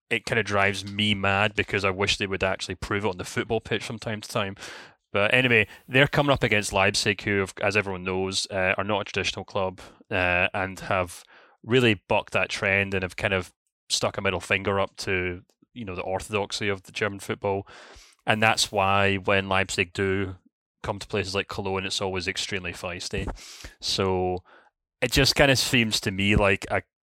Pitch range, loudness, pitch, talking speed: 95-110 Hz, -25 LUFS, 100 Hz, 200 wpm